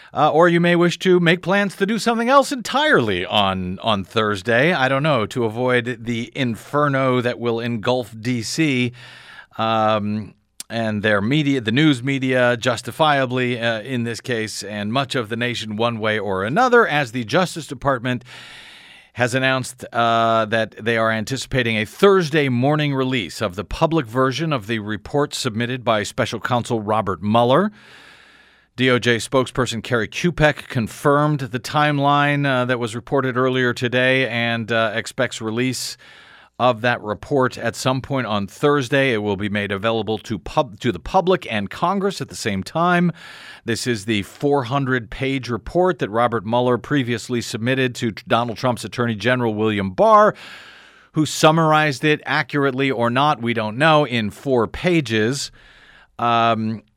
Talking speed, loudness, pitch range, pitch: 155 wpm, -19 LUFS, 115-145 Hz, 125 Hz